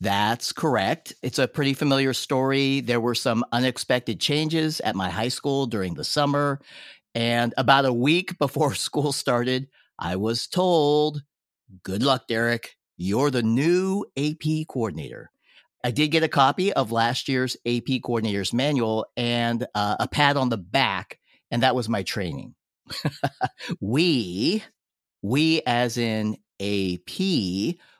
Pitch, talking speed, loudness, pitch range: 130 Hz, 140 wpm, -24 LUFS, 115-145 Hz